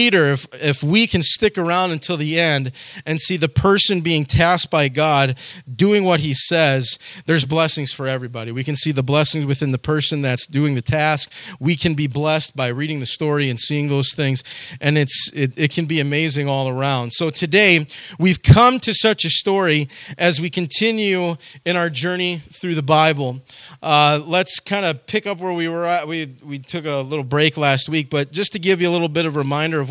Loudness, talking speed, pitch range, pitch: -17 LUFS, 210 wpm, 140-175 Hz, 155 Hz